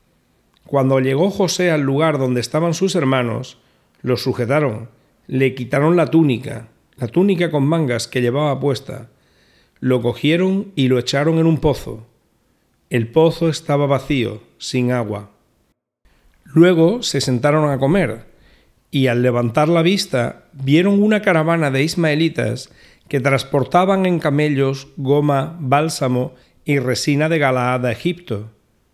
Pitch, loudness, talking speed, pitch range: 140 Hz, -17 LUFS, 130 wpm, 125-160 Hz